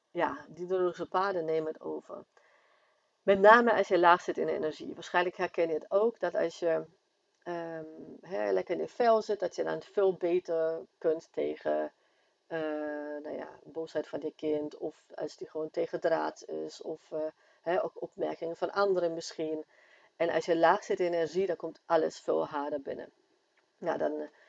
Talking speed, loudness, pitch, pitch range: 185 wpm, -31 LUFS, 165 Hz, 155-185 Hz